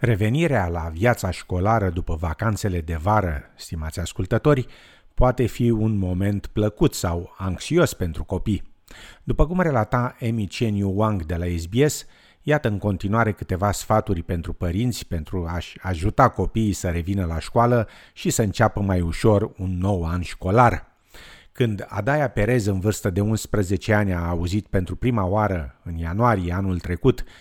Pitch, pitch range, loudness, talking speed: 100 Hz, 90-115 Hz, -23 LUFS, 150 wpm